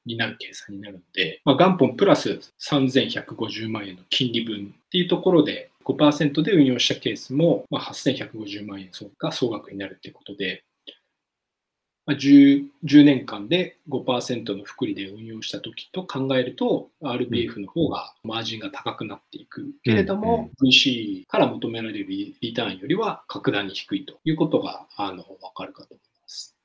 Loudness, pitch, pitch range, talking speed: -22 LUFS, 135 Hz, 110-170 Hz, 290 characters per minute